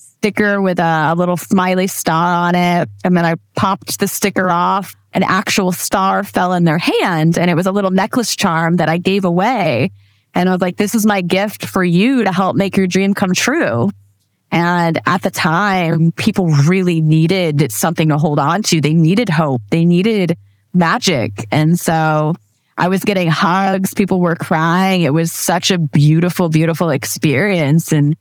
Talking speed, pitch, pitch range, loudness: 180 wpm, 175 Hz, 160-190 Hz, -14 LUFS